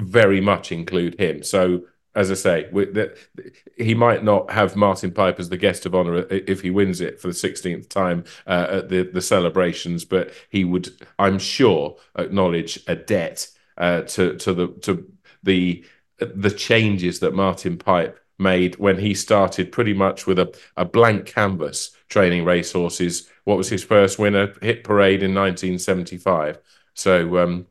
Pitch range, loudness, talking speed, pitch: 90-100 Hz, -20 LUFS, 165 wpm, 95 Hz